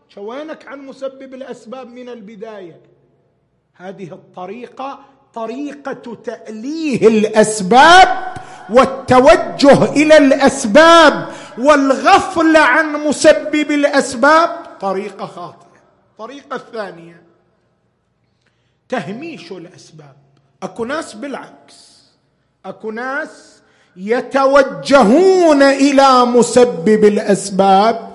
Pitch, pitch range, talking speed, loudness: 250 Hz, 205-290 Hz, 70 wpm, -11 LUFS